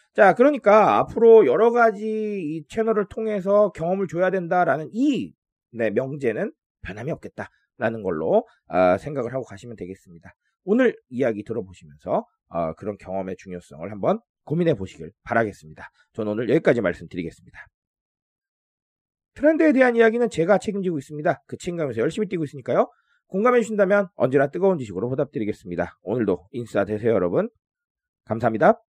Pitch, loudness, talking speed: 180 Hz, -22 LUFS, 385 characters per minute